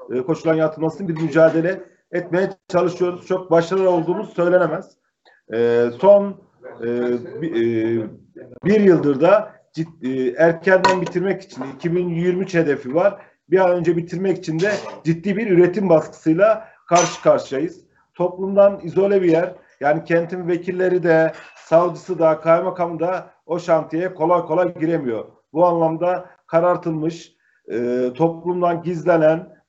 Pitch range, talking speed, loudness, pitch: 160-185 Hz, 120 wpm, -19 LUFS, 175 Hz